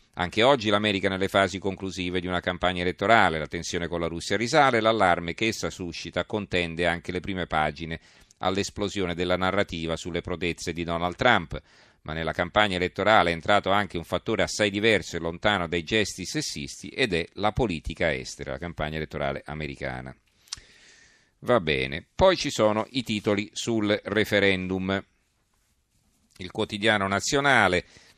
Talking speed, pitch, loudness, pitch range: 150 wpm, 90 Hz, -25 LUFS, 85-105 Hz